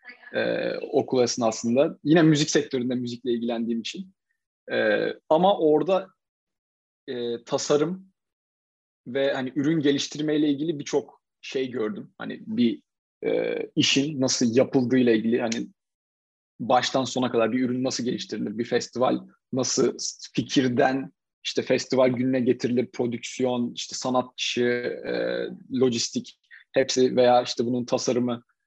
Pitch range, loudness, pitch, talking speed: 120-155 Hz, -25 LUFS, 130 Hz, 110 wpm